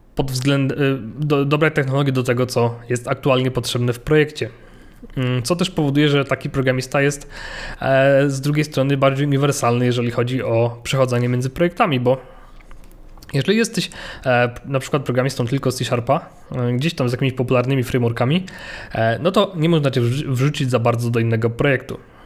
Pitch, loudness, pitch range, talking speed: 135 Hz, -19 LUFS, 125-145 Hz, 165 wpm